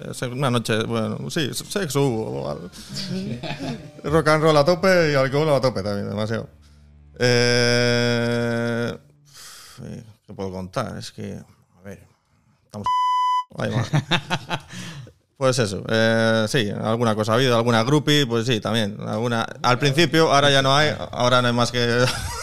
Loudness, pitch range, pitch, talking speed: -21 LUFS, 110-145 Hz, 120 Hz, 135 wpm